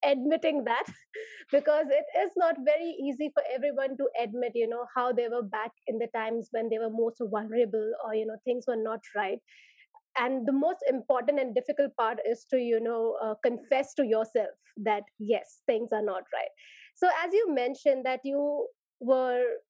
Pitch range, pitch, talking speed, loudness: 230-290 Hz, 255 Hz, 185 wpm, -29 LUFS